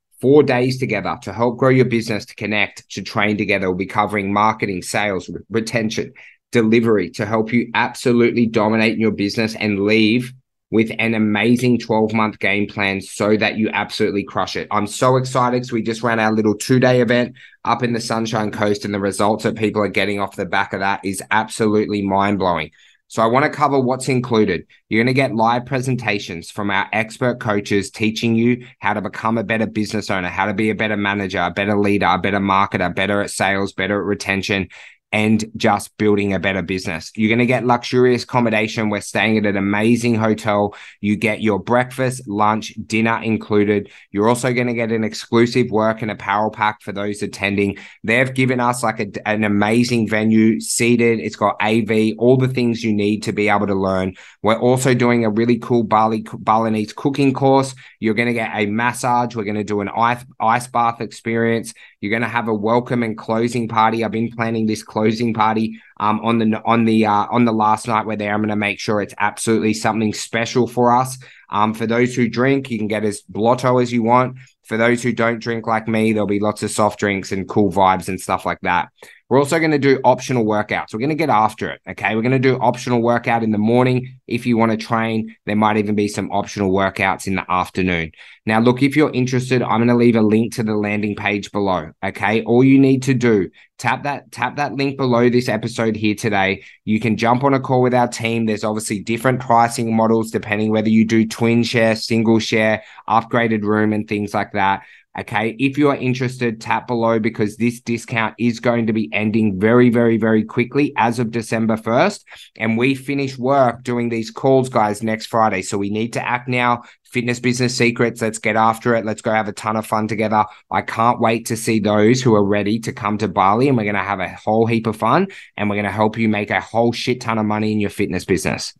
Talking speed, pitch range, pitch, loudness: 220 wpm, 105-120 Hz, 110 Hz, -18 LUFS